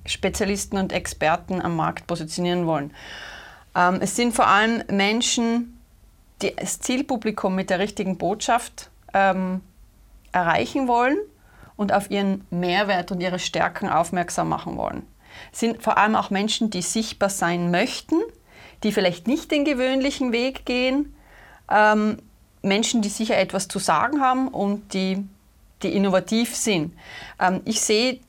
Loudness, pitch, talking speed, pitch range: -22 LUFS, 200 Hz, 140 wpm, 185-240 Hz